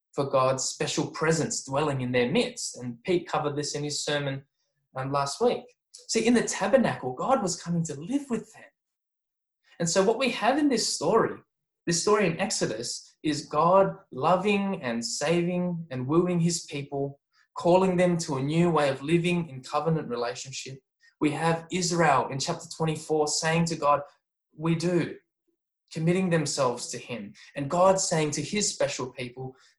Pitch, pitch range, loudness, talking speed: 165 Hz, 145-190 Hz, -27 LUFS, 165 wpm